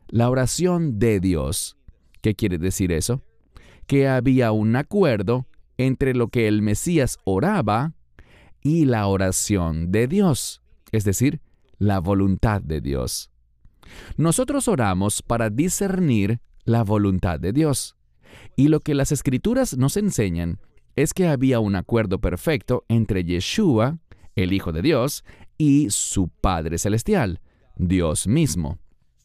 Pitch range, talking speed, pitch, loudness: 95-135 Hz, 125 wpm, 110 Hz, -22 LUFS